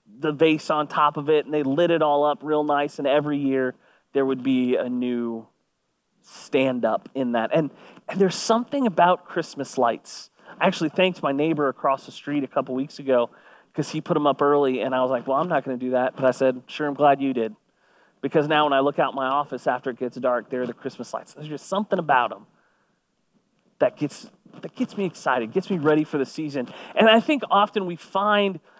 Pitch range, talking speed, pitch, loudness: 130-170 Hz, 230 wpm, 145 Hz, -23 LUFS